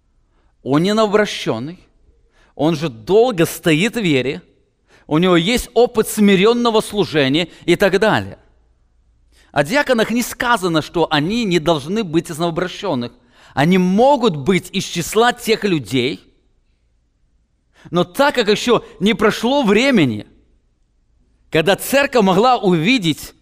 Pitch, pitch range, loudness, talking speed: 180 Hz, 145-220 Hz, -16 LUFS, 120 wpm